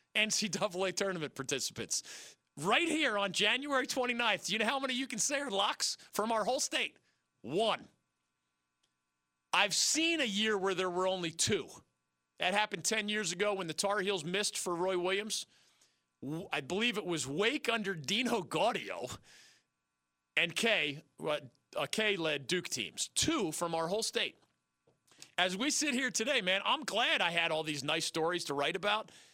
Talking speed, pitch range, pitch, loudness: 165 wpm, 145-220 Hz, 185 Hz, -33 LUFS